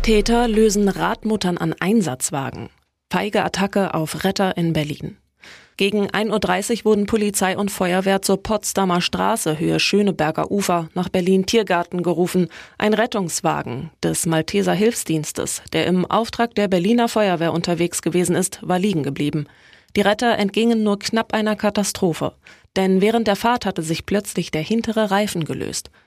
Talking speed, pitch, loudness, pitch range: 145 wpm, 190 Hz, -20 LUFS, 170-215 Hz